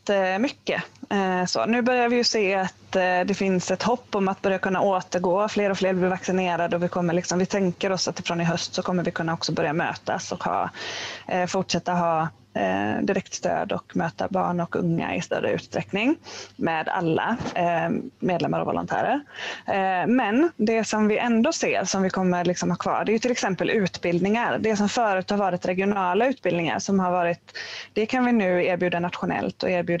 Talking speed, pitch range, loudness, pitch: 190 wpm, 180-215 Hz, -24 LUFS, 190 Hz